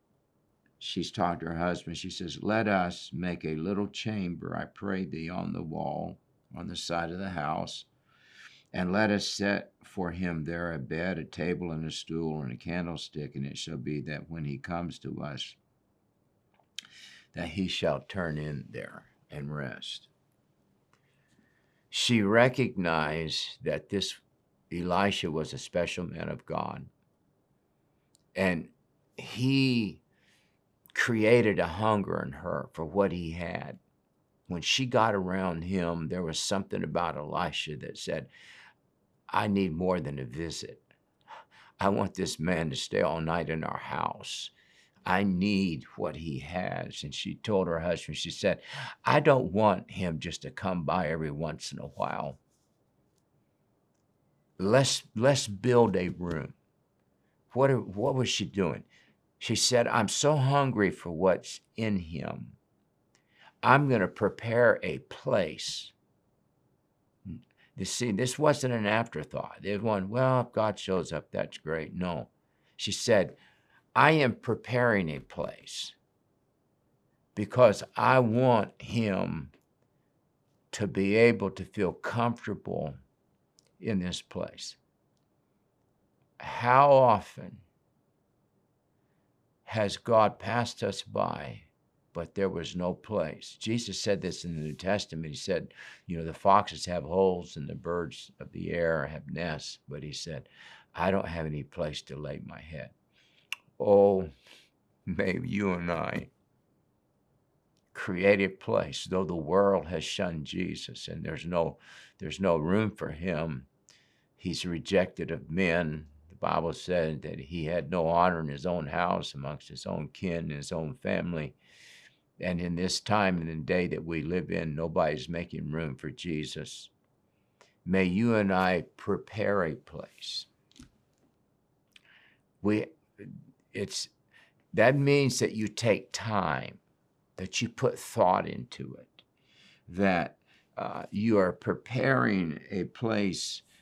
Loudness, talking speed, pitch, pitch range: -30 LUFS, 140 wpm, 90 Hz, 80-105 Hz